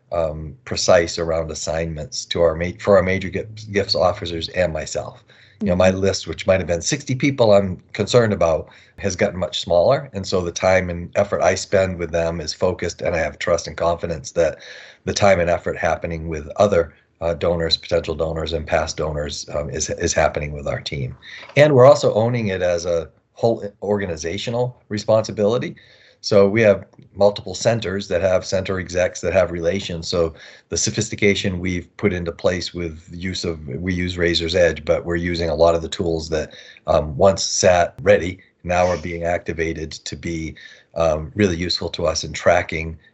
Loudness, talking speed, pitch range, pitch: -20 LUFS, 190 wpm, 85-100 Hz, 90 Hz